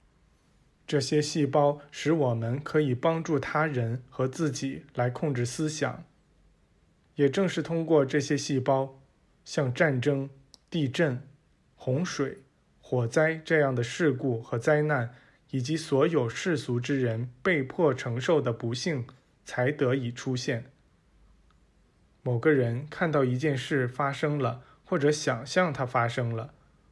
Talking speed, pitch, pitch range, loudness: 190 characters per minute, 135 Hz, 125-150 Hz, -28 LUFS